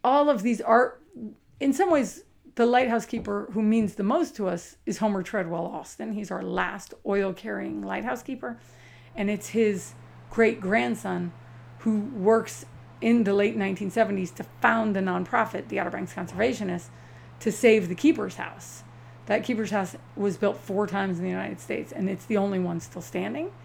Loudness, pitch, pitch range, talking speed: -26 LUFS, 205 Hz, 180-225 Hz, 170 wpm